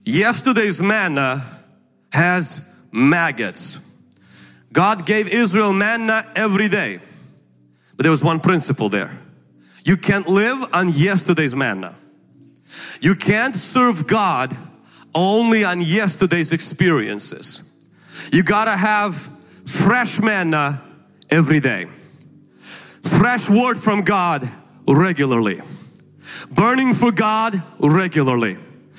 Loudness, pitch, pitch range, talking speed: -17 LUFS, 180 Hz, 150-215 Hz, 95 wpm